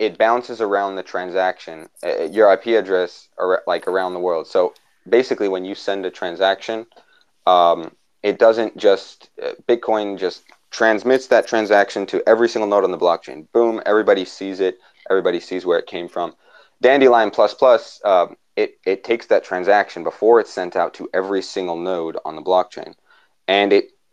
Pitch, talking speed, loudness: 110 Hz, 170 wpm, -18 LUFS